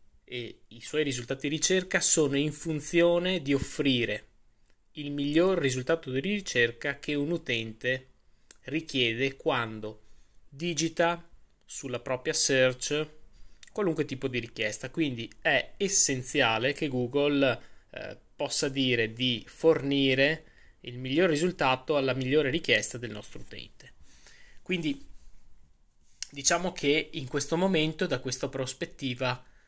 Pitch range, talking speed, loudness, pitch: 125-155 Hz, 115 wpm, -28 LUFS, 140 Hz